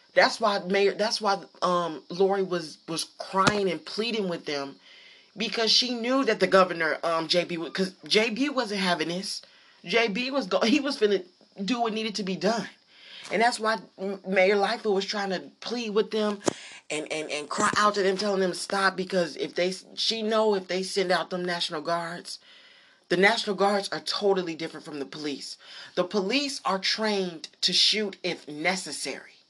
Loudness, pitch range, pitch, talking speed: -26 LUFS, 175-220 Hz, 195 Hz, 190 wpm